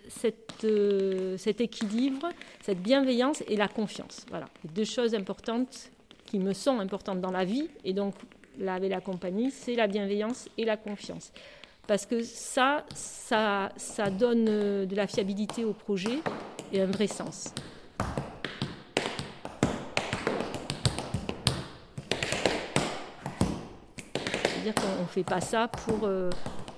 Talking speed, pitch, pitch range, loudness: 130 wpm, 215 Hz, 195-235 Hz, -31 LUFS